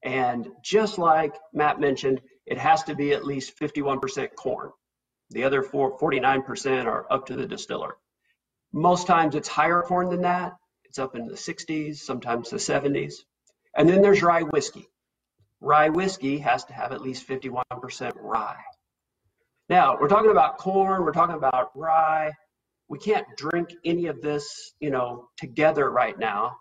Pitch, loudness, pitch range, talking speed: 150 Hz, -24 LUFS, 135-170 Hz, 160 wpm